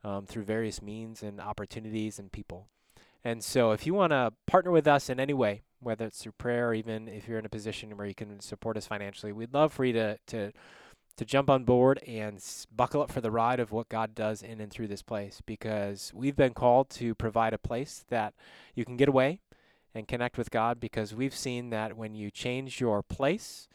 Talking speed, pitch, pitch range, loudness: 225 wpm, 115 Hz, 105-125 Hz, -31 LUFS